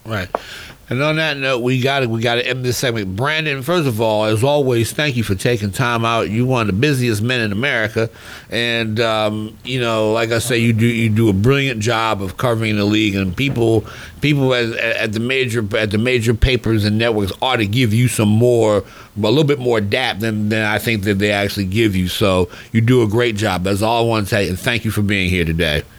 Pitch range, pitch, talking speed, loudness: 105-125 Hz, 115 Hz, 240 wpm, -17 LUFS